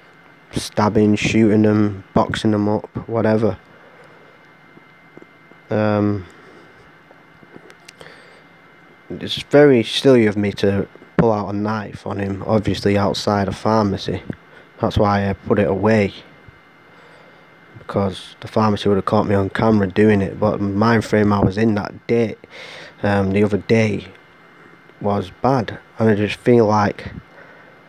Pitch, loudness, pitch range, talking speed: 105 Hz, -18 LUFS, 100-110 Hz, 130 wpm